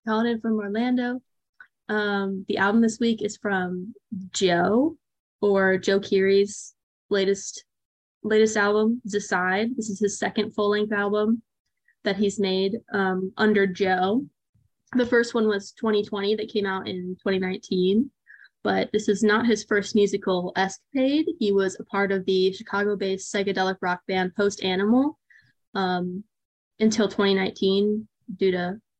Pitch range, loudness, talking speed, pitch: 195-220 Hz, -24 LUFS, 135 wpm, 205 Hz